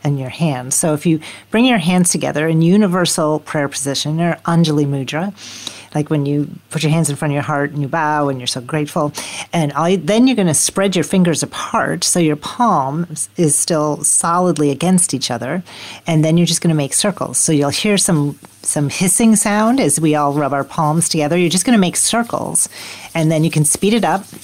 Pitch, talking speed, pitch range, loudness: 160 Hz, 220 wpm, 150-180 Hz, -15 LUFS